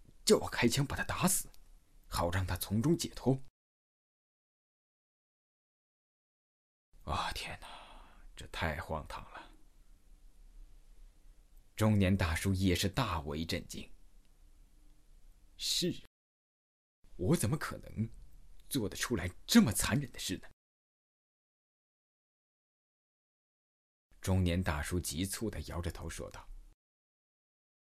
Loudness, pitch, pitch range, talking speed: -34 LUFS, 90 Hz, 75-100 Hz, 135 characters per minute